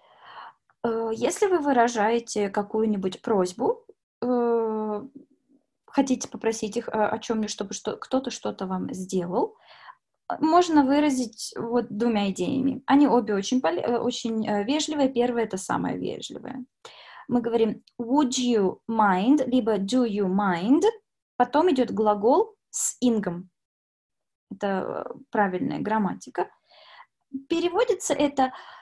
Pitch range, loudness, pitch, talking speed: 215-275 Hz, -25 LUFS, 240 Hz, 100 wpm